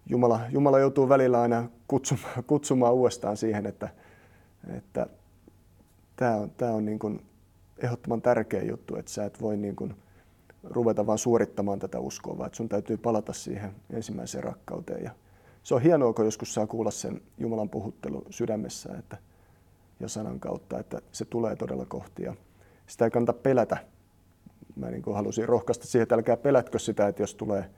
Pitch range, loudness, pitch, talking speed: 100-120 Hz, -28 LUFS, 110 Hz, 165 wpm